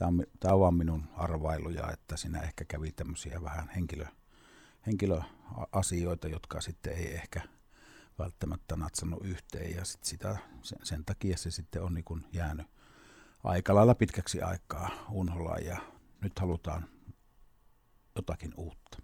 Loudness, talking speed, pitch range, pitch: -34 LUFS, 125 wpm, 80-95 Hz, 85 Hz